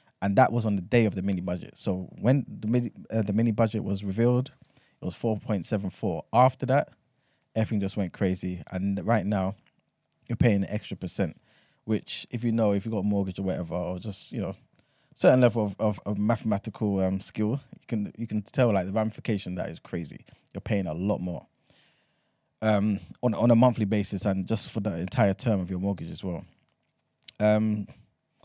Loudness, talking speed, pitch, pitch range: -27 LUFS, 205 wpm, 105 Hz, 95-115 Hz